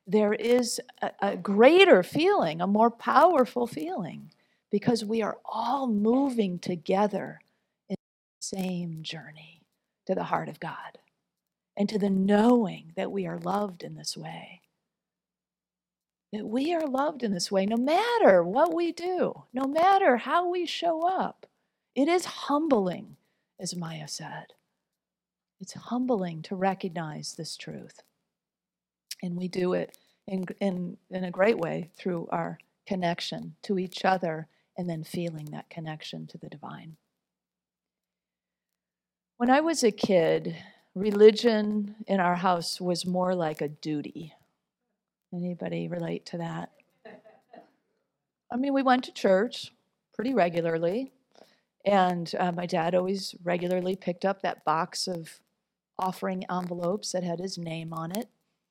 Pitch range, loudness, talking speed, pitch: 175-235 Hz, -27 LUFS, 140 wpm, 195 Hz